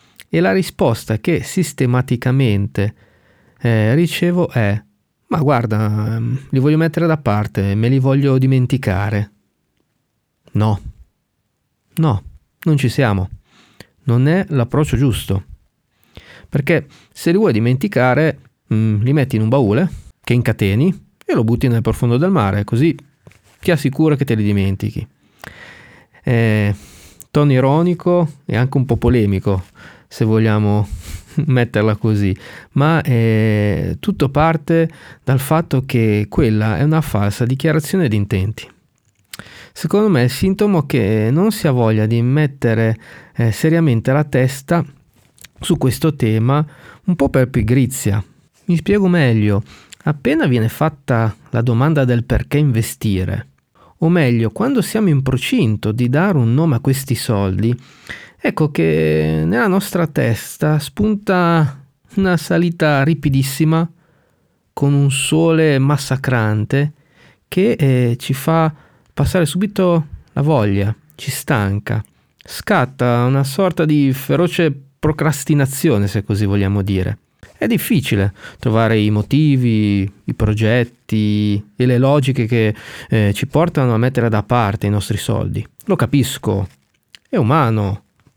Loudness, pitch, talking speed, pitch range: -16 LUFS, 125 Hz, 125 wpm, 110-150 Hz